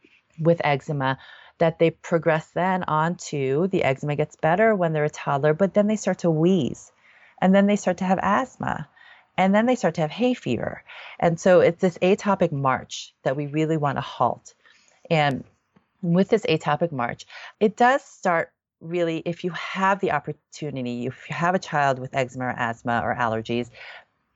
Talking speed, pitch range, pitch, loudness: 180 wpm, 145-190 Hz, 165 Hz, -23 LUFS